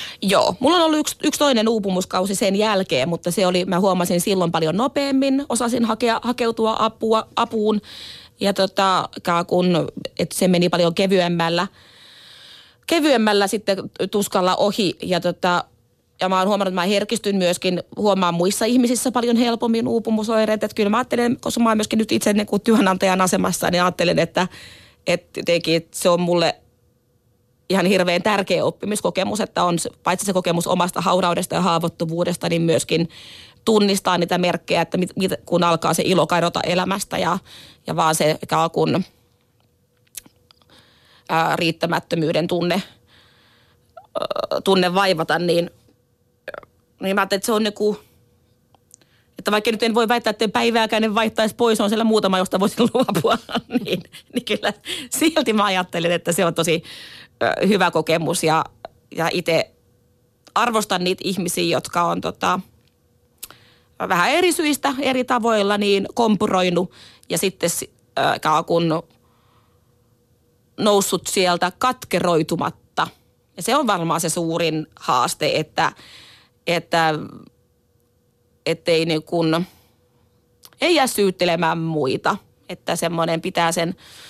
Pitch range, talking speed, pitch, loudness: 170-220 Hz, 130 wpm, 185 Hz, -20 LUFS